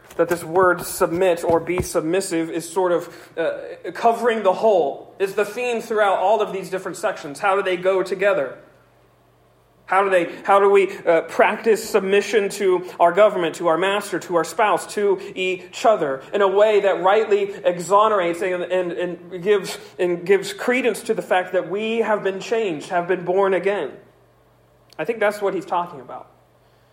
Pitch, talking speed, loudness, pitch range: 190 Hz, 180 wpm, -20 LUFS, 175-205 Hz